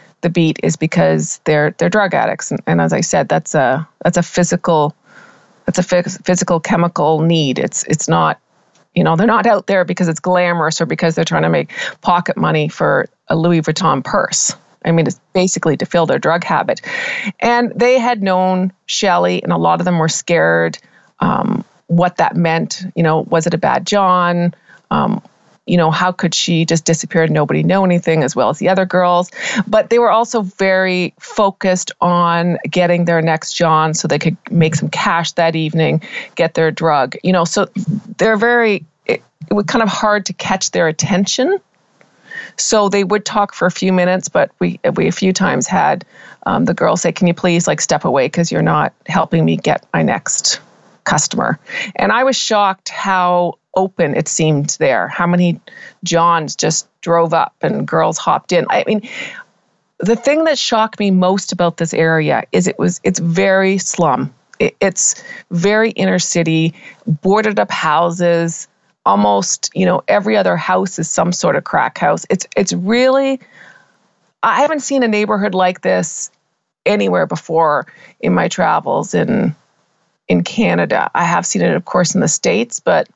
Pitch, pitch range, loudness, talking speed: 175 Hz, 165-200 Hz, -15 LUFS, 185 wpm